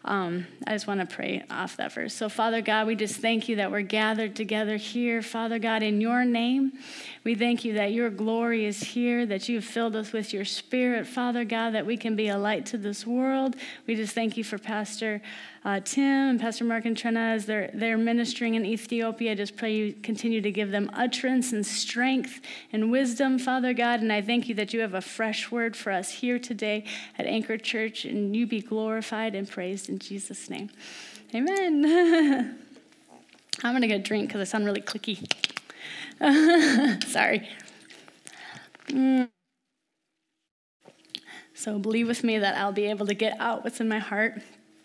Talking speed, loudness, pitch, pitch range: 190 wpm, -27 LUFS, 225 Hz, 215-240 Hz